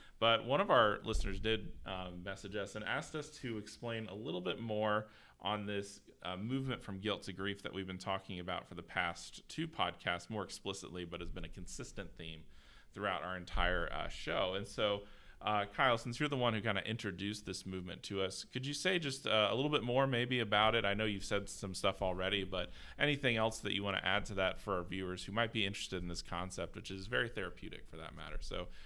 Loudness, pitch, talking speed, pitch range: -38 LUFS, 100 Hz, 235 wpm, 95-110 Hz